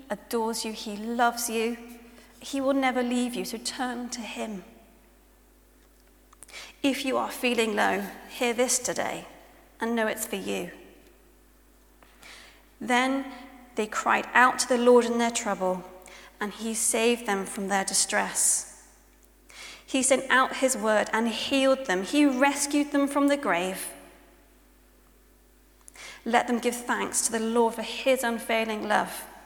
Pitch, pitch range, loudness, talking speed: 235 Hz, 220-255 Hz, -26 LUFS, 140 wpm